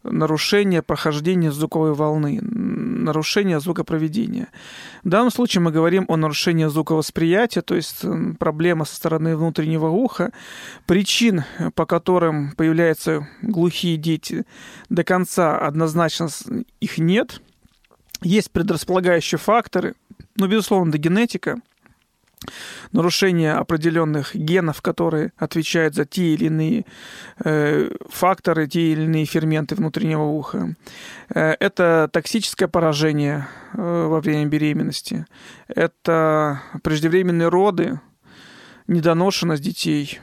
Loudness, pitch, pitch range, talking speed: -20 LUFS, 170 Hz, 155-185 Hz, 100 wpm